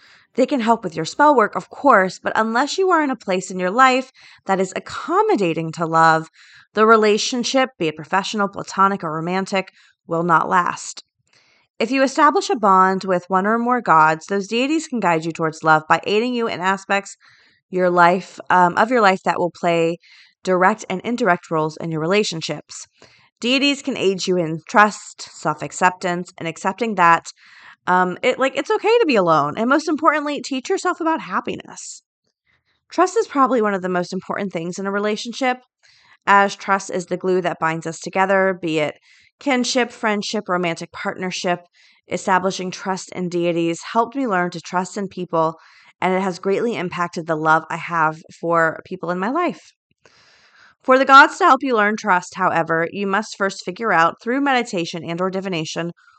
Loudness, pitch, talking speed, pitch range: -19 LUFS, 190 Hz, 180 wpm, 175-235 Hz